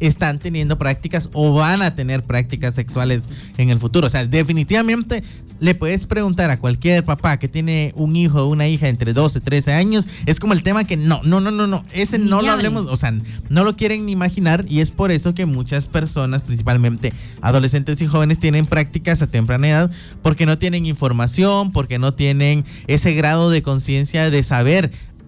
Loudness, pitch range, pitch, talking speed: -17 LUFS, 135-175 Hz, 155 Hz, 195 wpm